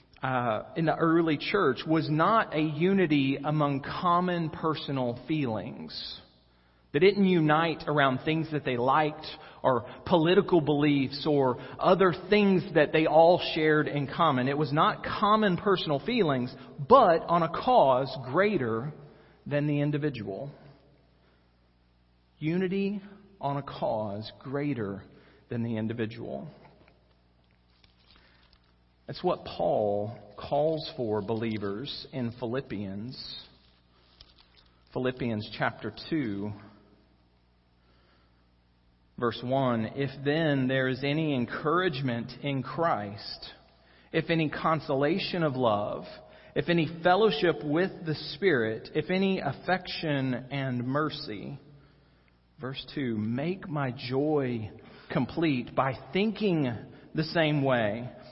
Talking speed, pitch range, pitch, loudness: 105 wpm, 110-160 Hz, 140 Hz, -28 LUFS